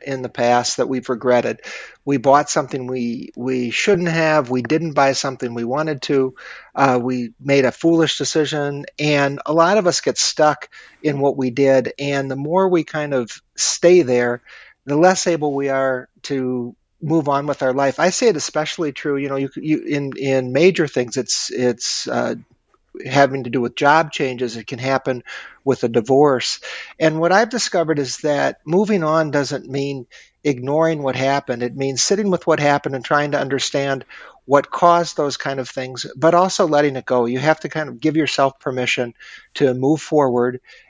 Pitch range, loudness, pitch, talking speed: 130-155 Hz, -18 LUFS, 140 Hz, 190 wpm